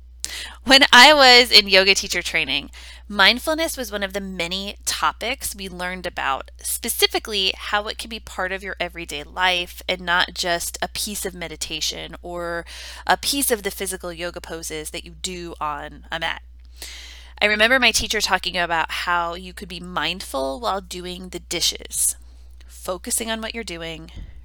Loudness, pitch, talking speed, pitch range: -19 LUFS, 180 Hz, 165 wpm, 165-205 Hz